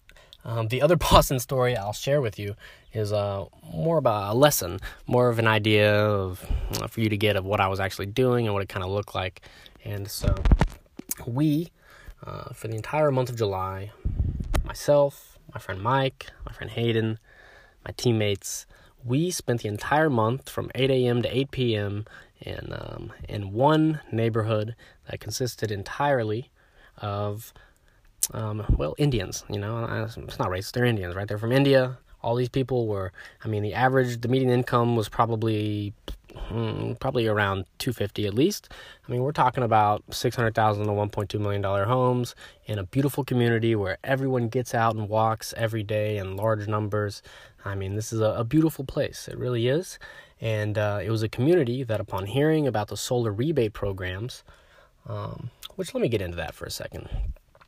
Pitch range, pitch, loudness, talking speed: 105-125 Hz, 110 Hz, -26 LUFS, 185 wpm